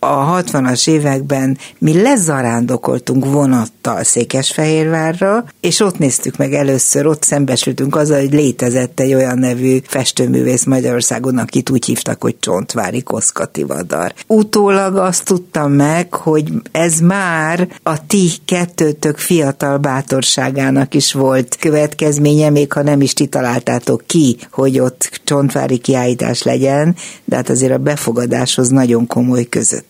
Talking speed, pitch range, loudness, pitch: 130 wpm, 130-160 Hz, -13 LUFS, 140 Hz